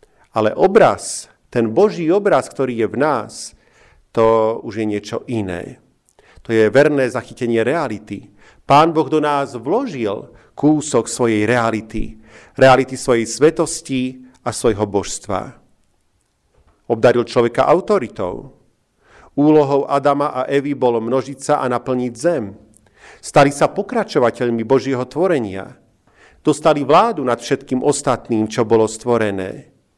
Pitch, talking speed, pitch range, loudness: 130 Hz, 120 wpm, 115-145 Hz, -17 LUFS